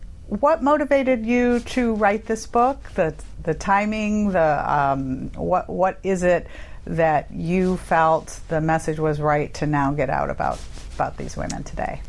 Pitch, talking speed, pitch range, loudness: 185 Hz, 160 wpm, 160-230 Hz, -22 LUFS